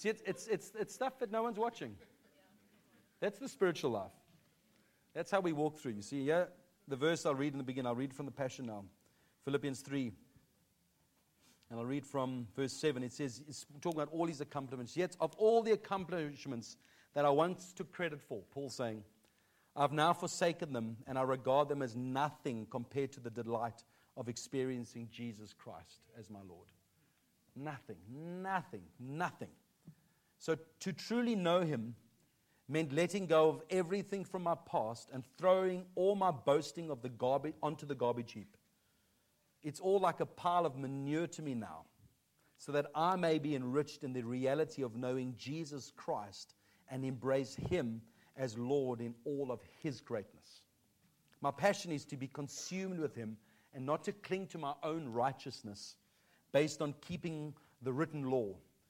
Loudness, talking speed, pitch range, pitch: -38 LUFS, 170 wpm, 125-170 Hz, 145 Hz